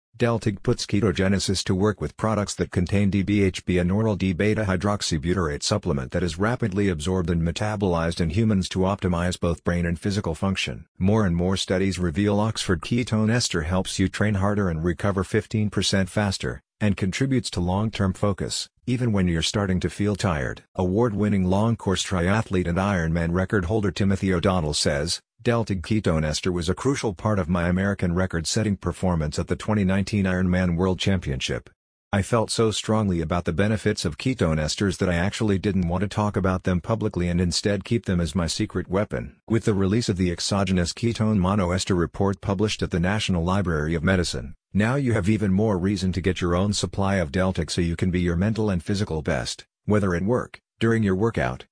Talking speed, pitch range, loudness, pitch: 185 wpm, 90-105 Hz, -24 LUFS, 95 Hz